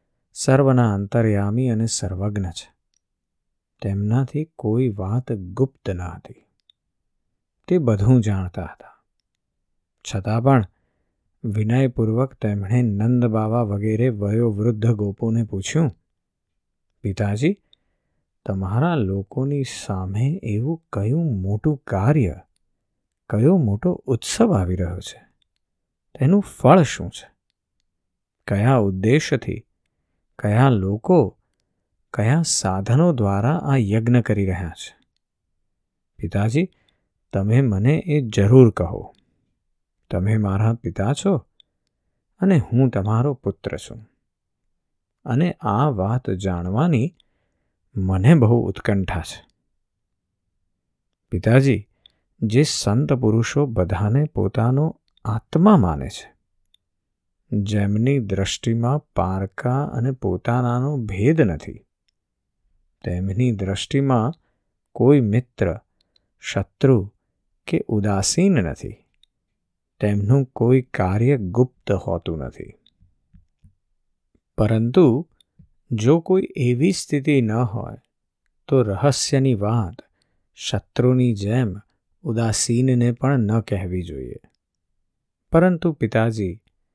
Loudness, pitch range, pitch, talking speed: -20 LUFS, 95-130 Hz, 110 Hz, 90 wpm